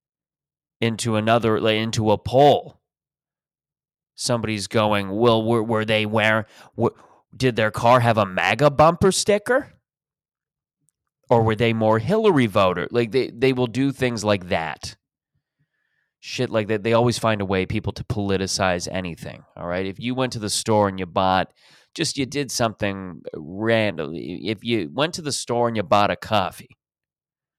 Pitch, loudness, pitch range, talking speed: 115 Hz, -21 LUFS, 105-130 Hz, 165 wpm